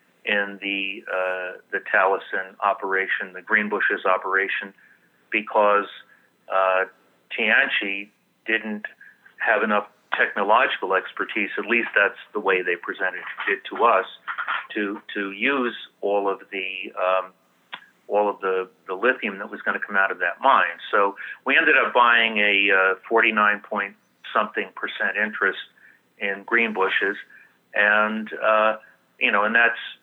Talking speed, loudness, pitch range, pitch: 130 wpm, -22 LUFS, 95-110 Hz, 100 Hz